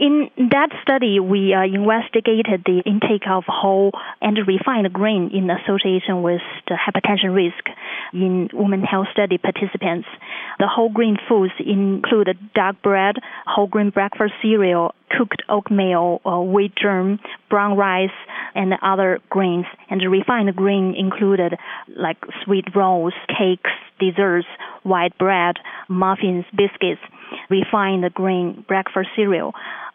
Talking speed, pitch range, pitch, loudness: 120 wpm, 185-210 Hz, 195 Hz, -19 LUFS